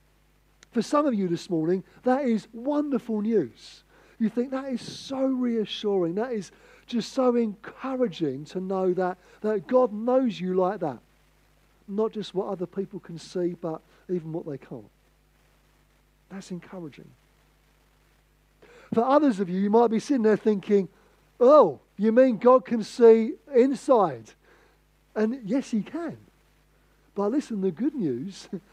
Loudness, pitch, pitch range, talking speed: -25 LUFS, 215 Hz, 185-245 Hz, 145 wpm